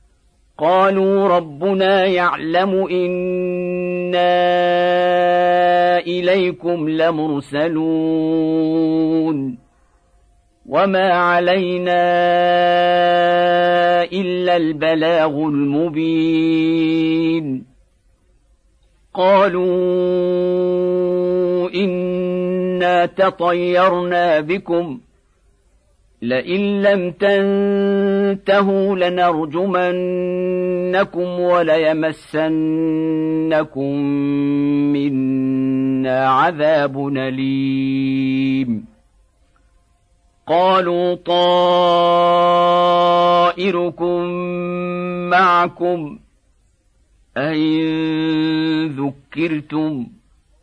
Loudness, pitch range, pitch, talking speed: -17 LUFS, 150-180 Hz, 175 Hz, 35 wpm